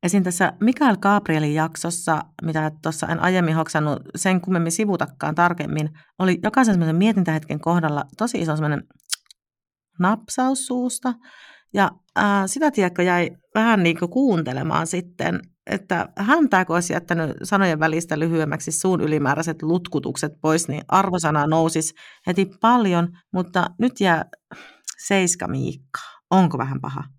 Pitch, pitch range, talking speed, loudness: 175 Hz, 160-200 Hz, 130 wpm, -21 LUFS